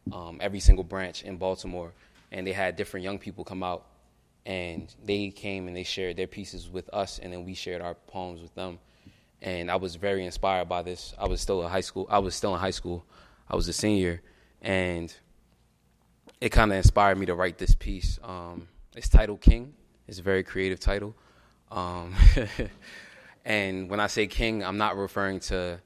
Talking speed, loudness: 195 wpm, -29 LUFS